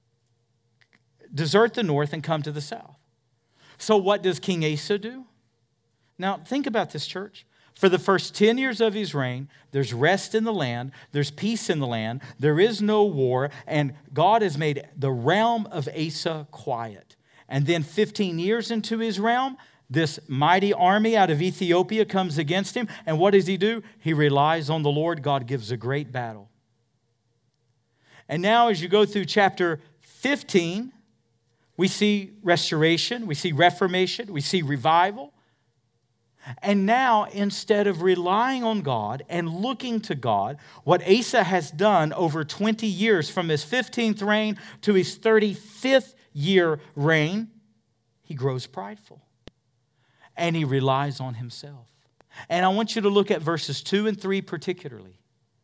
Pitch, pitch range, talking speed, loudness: 165 Hz, 140-205 Hz, 155 wpm, -24 LUFS